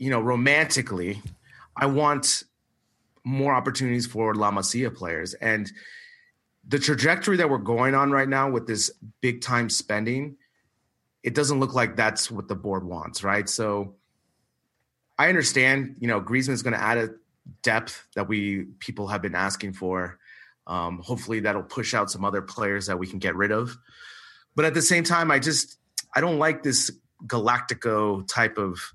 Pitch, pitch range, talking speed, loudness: 120 Hz, 100-135 Hz, 170 wpm, -24 LUFS